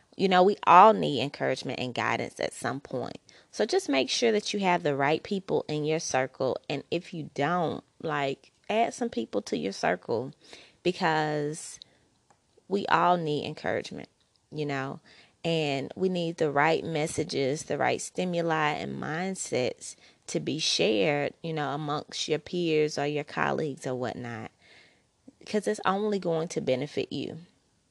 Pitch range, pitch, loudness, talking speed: 145-180 Hz, 155 Hz, -28 LUFS, 155 wpm